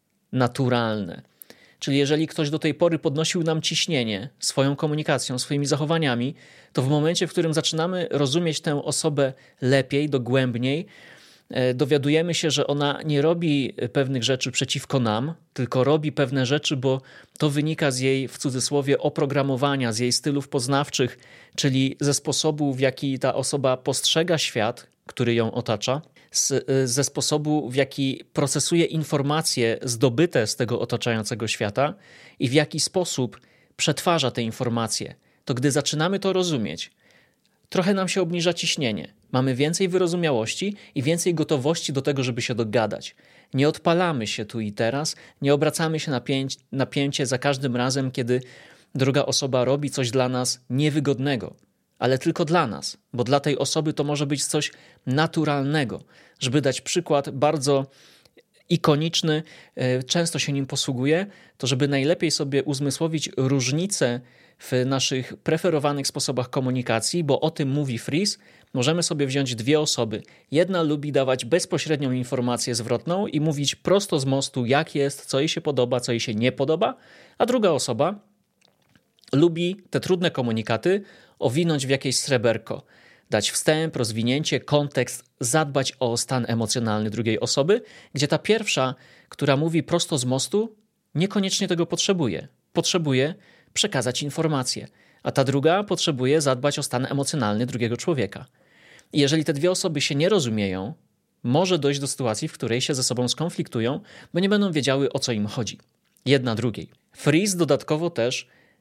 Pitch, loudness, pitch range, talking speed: 140 Hz, -23 LUFS, 130-160 Hz, 145 wpm